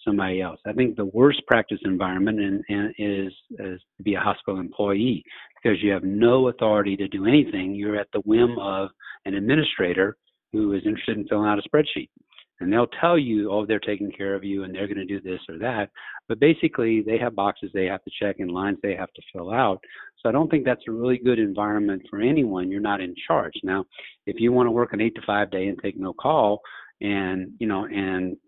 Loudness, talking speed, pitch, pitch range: -24 LUFS, 225 wpm, 105 Hz, 100-115 Hz